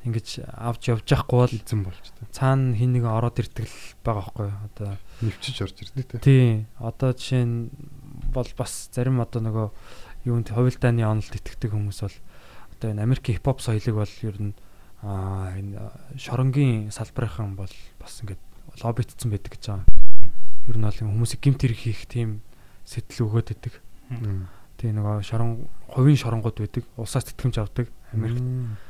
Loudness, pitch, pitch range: -26 LUFS, 115 Hz, 105-125 Hz